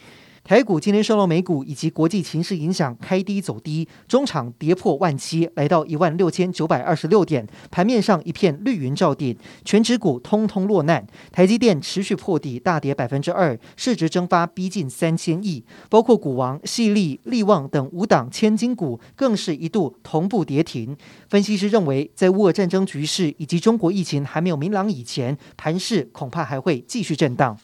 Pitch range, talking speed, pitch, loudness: 150-200 Hz, 290 characters per minute, 175 Hz, -21 LUFS